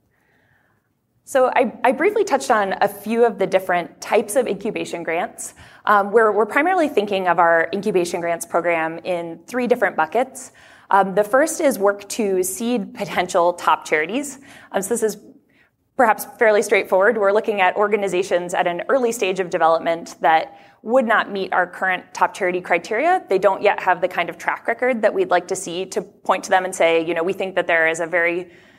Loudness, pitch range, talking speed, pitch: -19 LUFS, 175-225 Hz, 195 wpm, 195 Hz